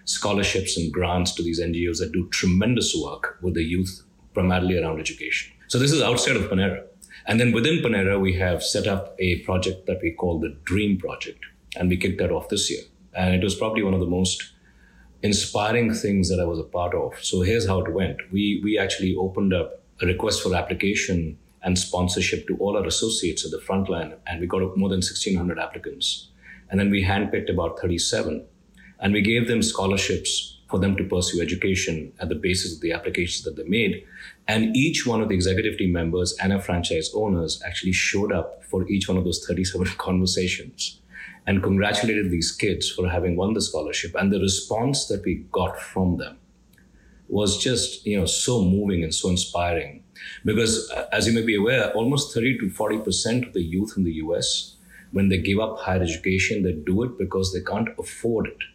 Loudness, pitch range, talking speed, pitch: -23 LUFS, 90-100 Hz, 200 wpm, 95 Hz